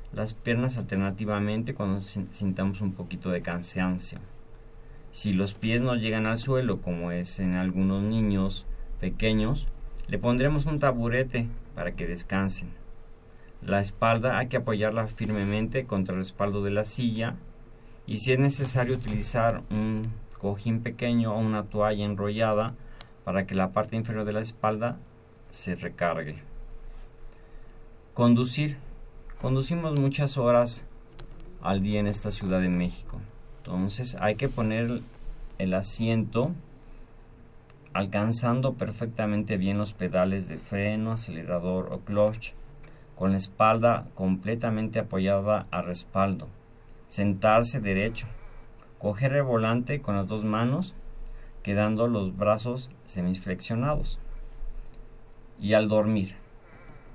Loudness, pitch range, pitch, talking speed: -28 LUFS, 100-115 Hz, 110 Hz, 120 wpm